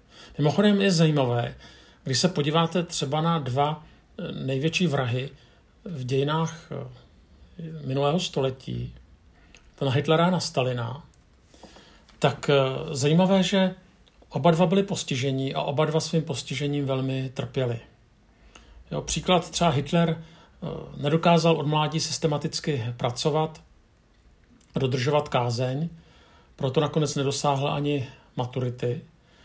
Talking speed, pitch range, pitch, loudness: 105 wpm, 130-165 Hz, 145 Hz, -25 LUFS